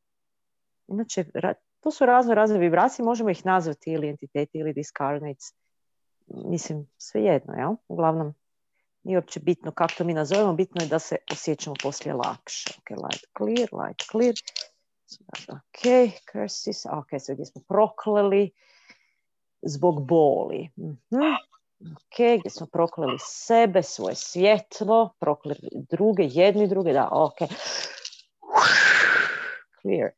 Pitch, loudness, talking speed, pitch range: 185 Hz, -24 LUFS, 125 wpm, 155-220 Hz